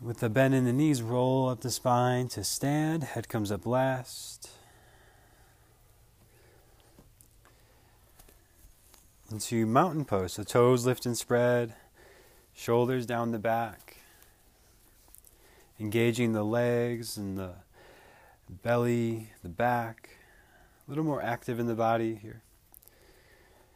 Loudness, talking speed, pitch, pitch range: -29 LUFS, 115 wpm, 115 Hz, 110-125 Hz